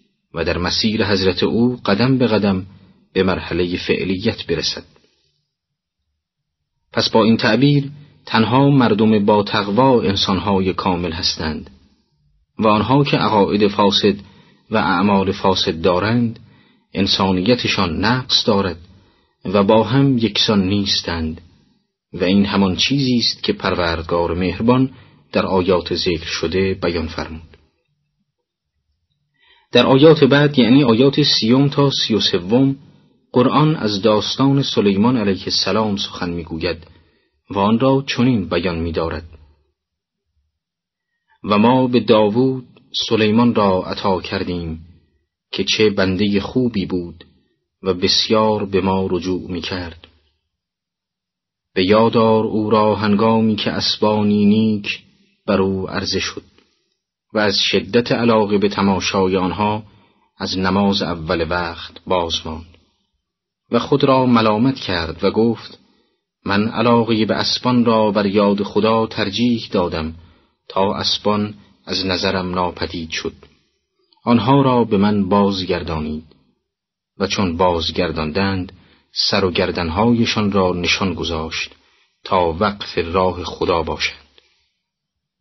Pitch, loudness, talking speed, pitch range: 100 Hz, -17 LUFS, 115 wpm, 90-115 Hz